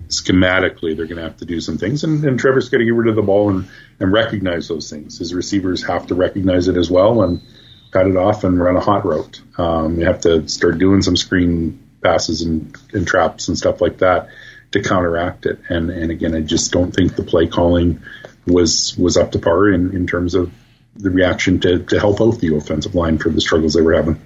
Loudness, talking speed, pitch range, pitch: -16 LUFS, 230 wpm, 85-105 Hz, 90 Hz